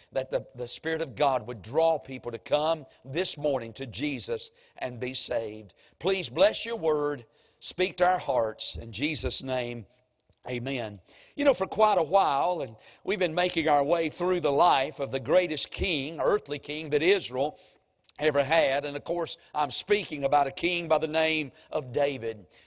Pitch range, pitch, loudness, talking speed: 130-170 Hz, 150 Hz, -28 LUFS, 180 wpm